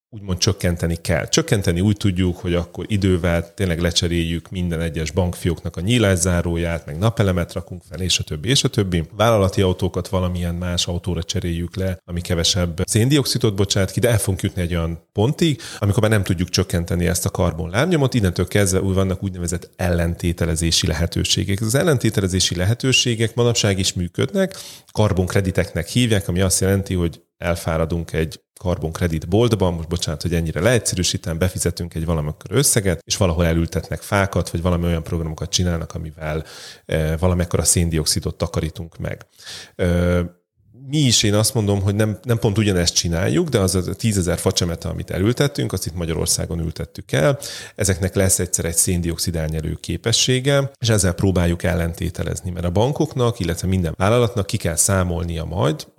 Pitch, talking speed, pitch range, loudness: 90 Hz, 155 wpm, 85-105 Hz, -20 LUFS